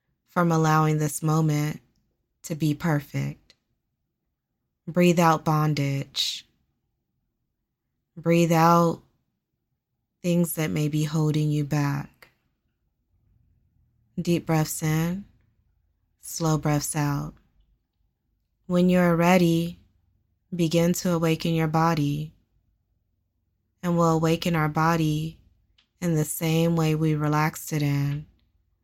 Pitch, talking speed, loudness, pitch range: 155 Hz, 100 wpm, -24 LUFS, 130-165 Hz